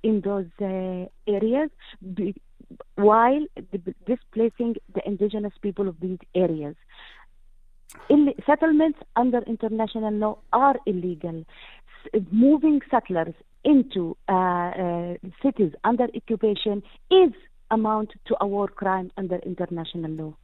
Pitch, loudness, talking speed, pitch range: 205 Hz, -24 LUFS, 115 wpm, 185-235 Hz